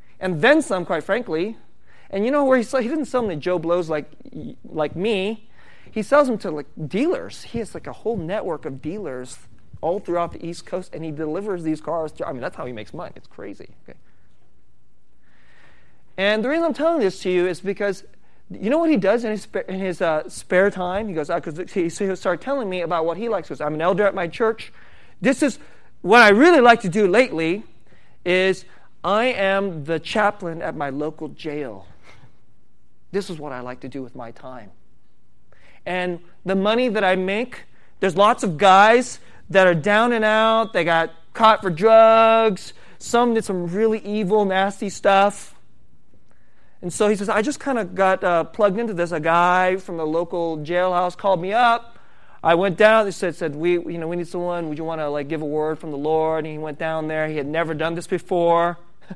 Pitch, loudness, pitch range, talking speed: 180 Hz, -20 LUFS, 160-215 Hz, 215 wpm